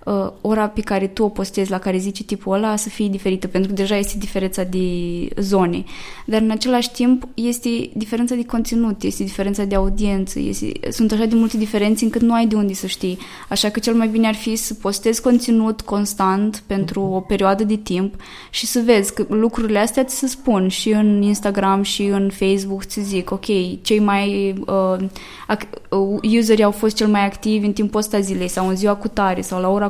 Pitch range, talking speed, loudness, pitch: 195-220 Hz, 205 wpm, -19 LUFS, 205 Hz